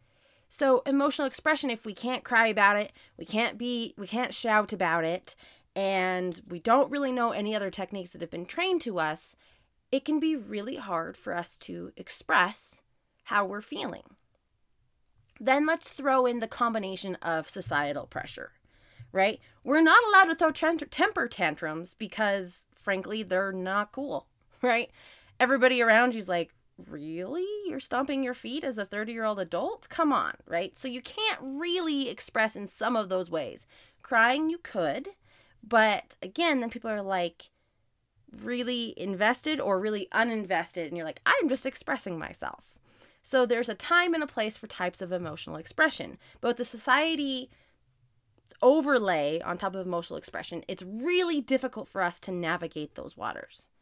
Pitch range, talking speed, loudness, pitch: 185-265 Hz, 165 wpm, -28 LUFS, 220 Hz